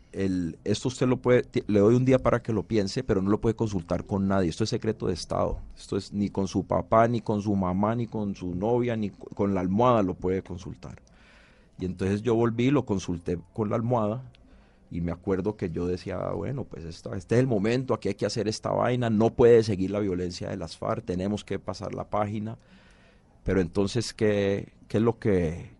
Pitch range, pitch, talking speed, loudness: 95-115 Hz, 105 Hz, 220 wpm, -27 LUFS